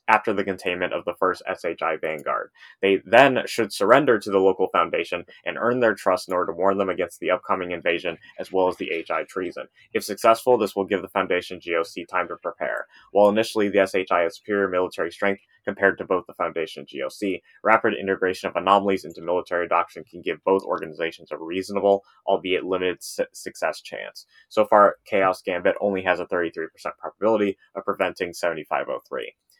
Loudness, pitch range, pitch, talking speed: -23 LUFS, 95-110 Hz, 100 Hz, 190 wpm